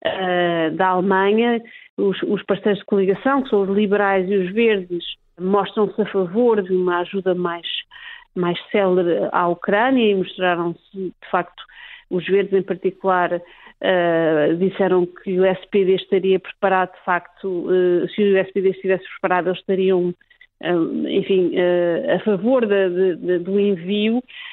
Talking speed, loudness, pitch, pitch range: 145 wpm, -19 LUFS, 190 Hz, 180-205 Hz